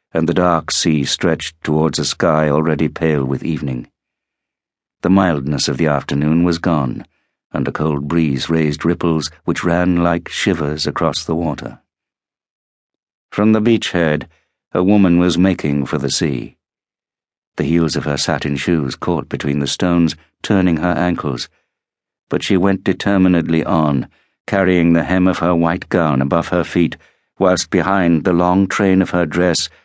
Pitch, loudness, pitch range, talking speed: 85 Hz, -16 LUFS, 75-90 Hz, 155 wpm